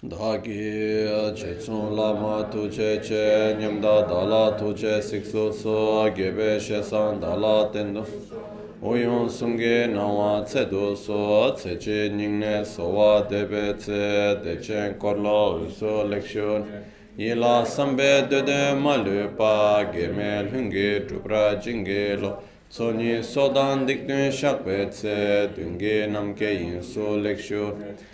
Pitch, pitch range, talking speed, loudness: 105 Hz, 105-110 Hz, 100 wpm, -24 LUFS